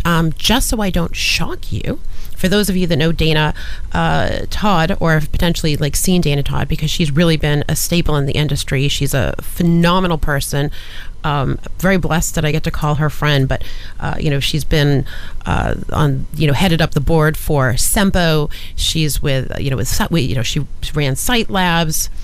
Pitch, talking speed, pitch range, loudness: 155 Hz, 195 wpm, 140-170 Hz, -16 LUFS